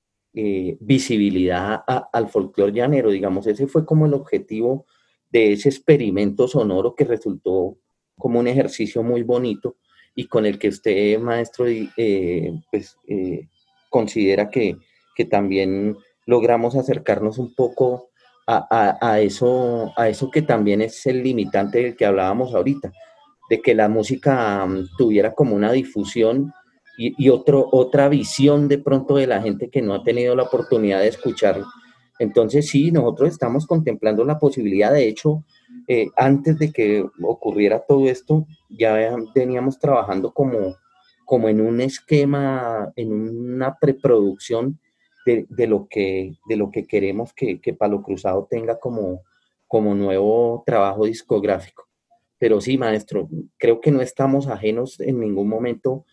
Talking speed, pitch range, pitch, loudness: 145 wpm, 105-135 Hz, 120 Hz, -19 LUFS